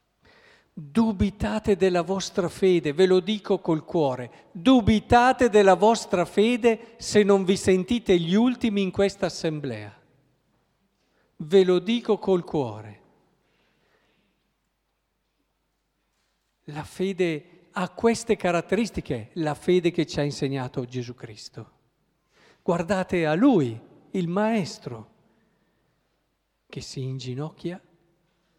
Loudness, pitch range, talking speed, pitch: -23 LUFS, 160-210 Hz, 100 wpm, 185 Hz